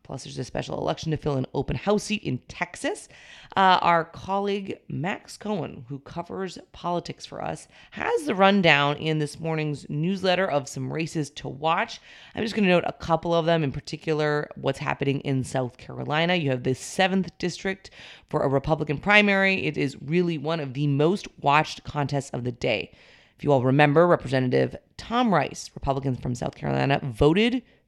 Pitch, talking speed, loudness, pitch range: 155 Hz, 180 wpm, -25 LUFS, 140-180 Hz